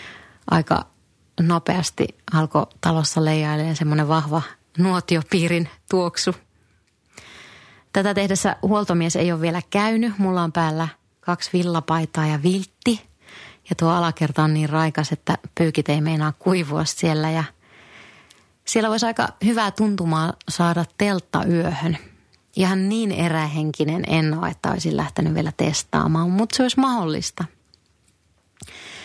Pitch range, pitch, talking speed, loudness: 155-185 Hz, 165 Hz, 120 wpm, -21 LUFS